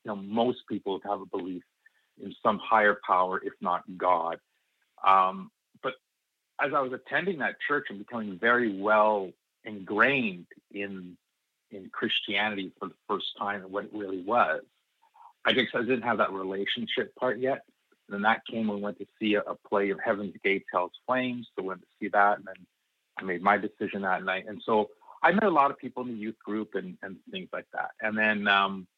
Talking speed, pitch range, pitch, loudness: 205 wpm, 95-110 Hz, 105 Hz, -28 LUFS